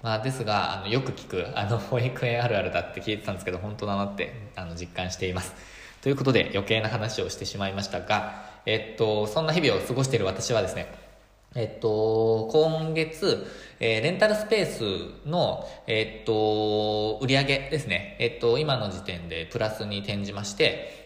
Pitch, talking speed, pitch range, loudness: 110 Hz, 365 characters per minute, 100-125 Hz, -27 LUFS